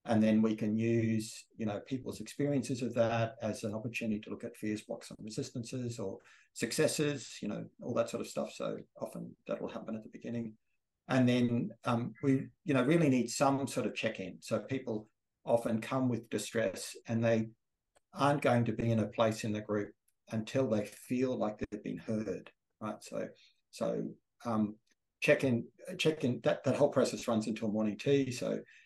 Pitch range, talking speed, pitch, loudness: 110-130 Hz, 185 wpm, 115 Hz, -34 LUFS